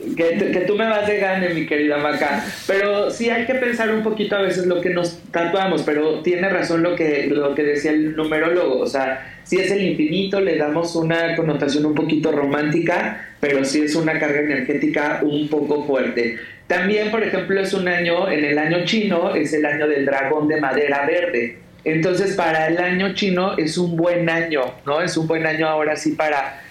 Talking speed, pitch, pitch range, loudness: 200 wpm, 160 Hz, 150-180 Hz, -19 LUFS